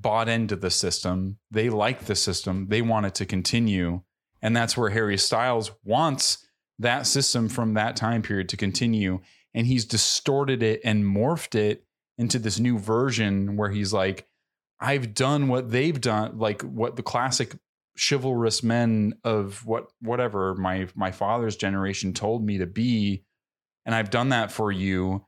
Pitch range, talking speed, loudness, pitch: 100-120 Hz, 165 wpm, -25 LUFS, 110 Hz